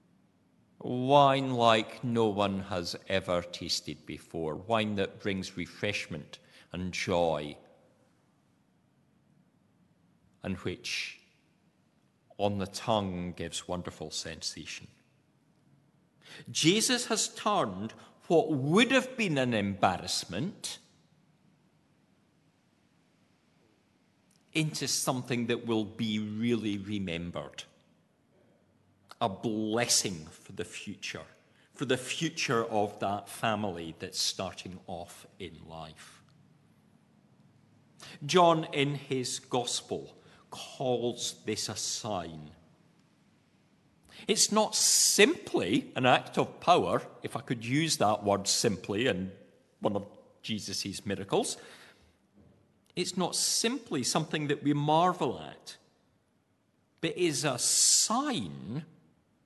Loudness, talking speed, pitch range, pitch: -30 LUFS, 95 wpm, 95-145 Hz, 115 Hz